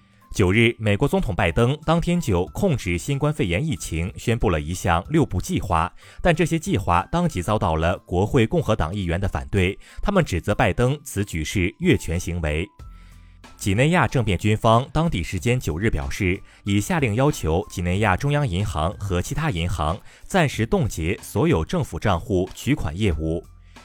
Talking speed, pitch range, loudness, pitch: 270 characters per minute, 90-135 Hz, -22 LUFS, 100 Hz